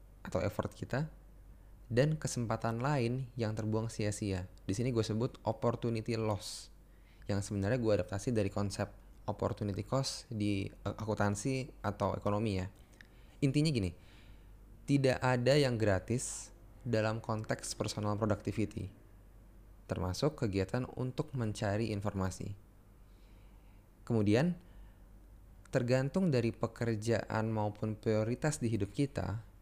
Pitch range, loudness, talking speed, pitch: 100-120 Hz, -35 LUFS, 105 wpm, 105 Hz